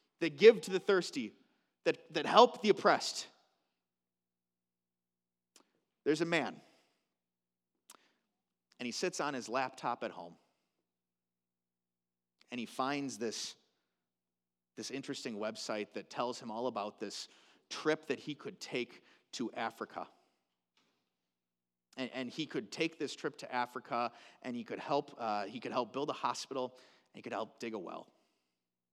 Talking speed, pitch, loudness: 140 wpm, 115 Hz, -36 LUFS